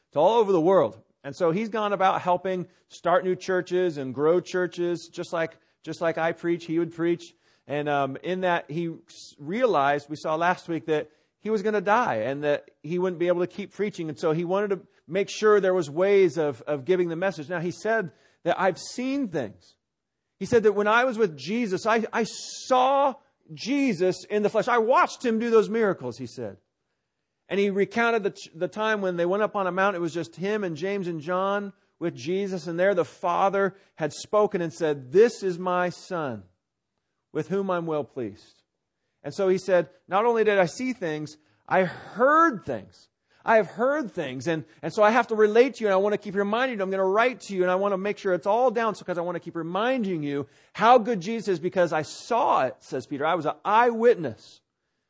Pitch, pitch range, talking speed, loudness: 185 Hz, 165-210 Hz, 225 wpm, -25 LUFS